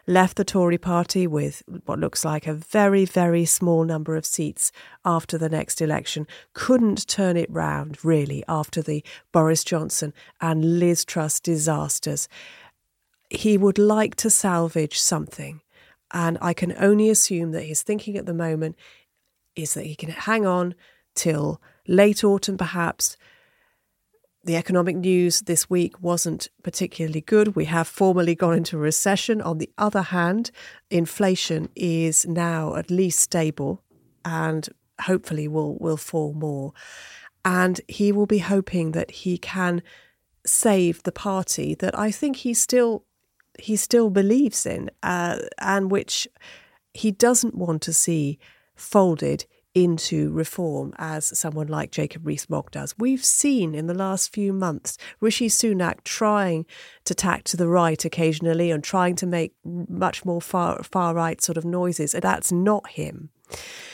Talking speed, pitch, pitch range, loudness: 150 wpm, 175 Hz, 160-200 Hz, -22 LUFS